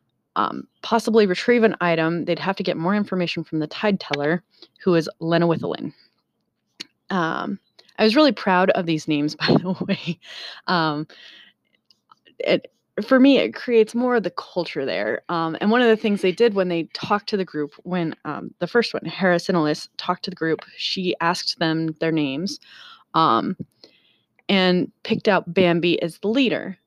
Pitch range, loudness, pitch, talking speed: 165-210 Hz, -21 LUFS, 180 Hz, 175 wpm